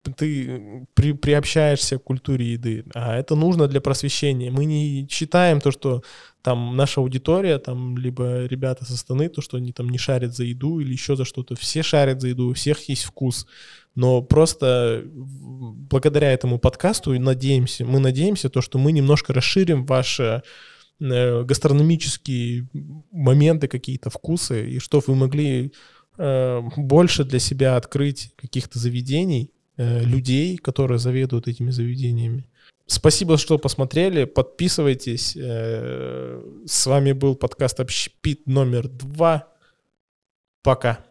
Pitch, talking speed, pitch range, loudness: 130 Hz, 130 wpm, 125-145 Hz, -21 LUFS